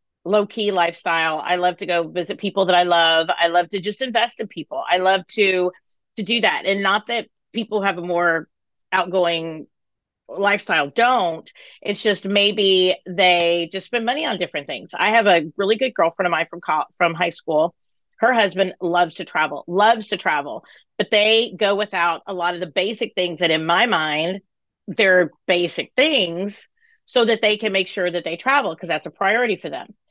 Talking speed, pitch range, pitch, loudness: 195 wpm, 175-210 Hz, 185 Hz, -19 LUFS